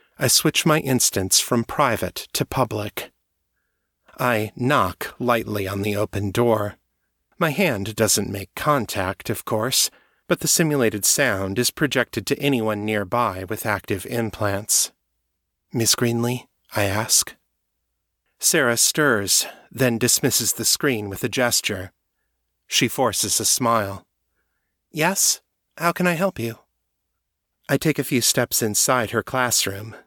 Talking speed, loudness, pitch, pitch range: 130 wpm, -20 LUFS, 115 Hz, 100-130 Hz